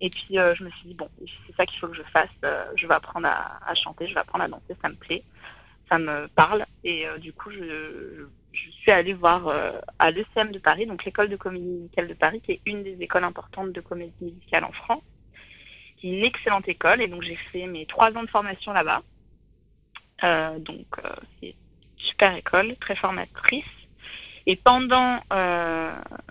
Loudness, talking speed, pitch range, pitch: -24 LUFS, 210 wpm, 170-210 Hz, 185 Hz